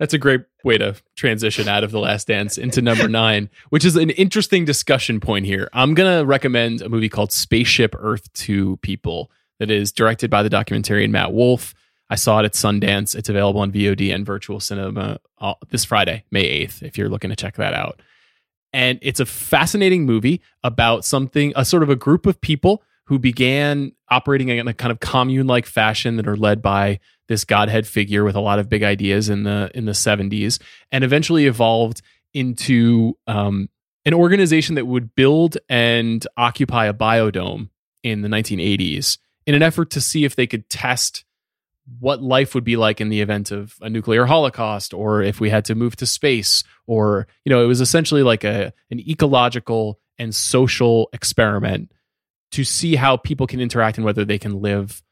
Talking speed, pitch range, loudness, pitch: 195 wpm, 105-135 Hz, -18 LUFS, 115 Hz